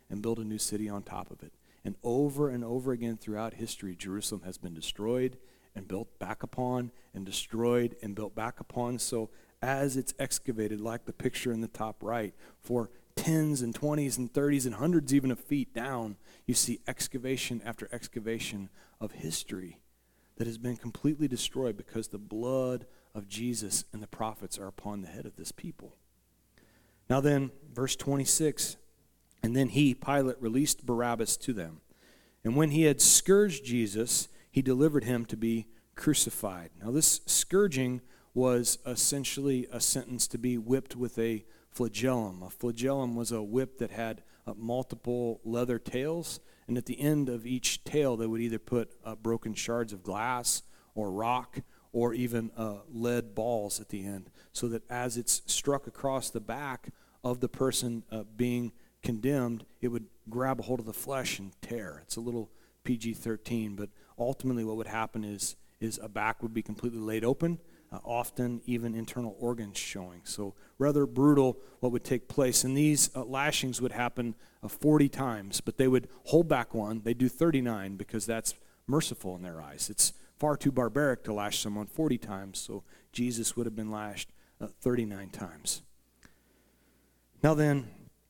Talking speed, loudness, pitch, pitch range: 175 wpm, -31 LUFS, 120 Hz, 110-130 Hz